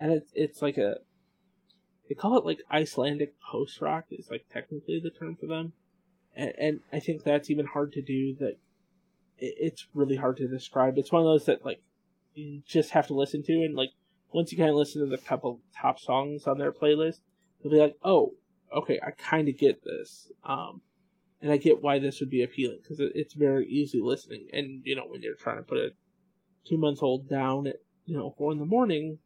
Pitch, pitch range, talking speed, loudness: 150 Hz, 140-185 Hz, 215 wpm, -29 LUFS